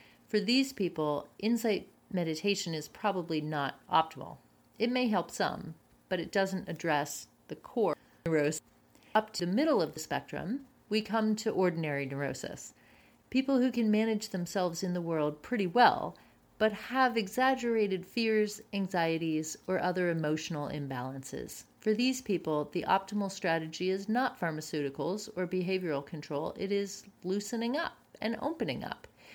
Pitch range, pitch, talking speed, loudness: 160-220 Hz, 190 Hz, 145 wpm, -32 LUFS